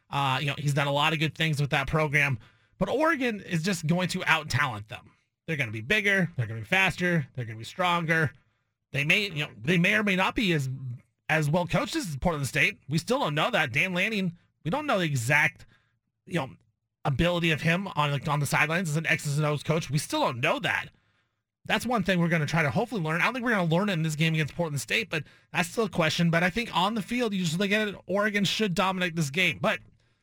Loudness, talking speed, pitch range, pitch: -26 LUFS, 255 wpm, 145-185 Hz, 160 Hz